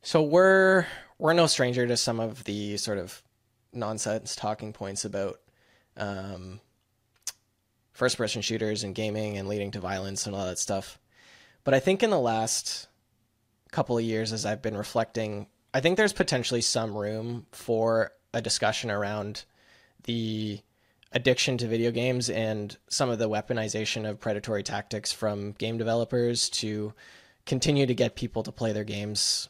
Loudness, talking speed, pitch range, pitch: -28 LUFS, 155 wpm, 105-120 Hz, 110 Hz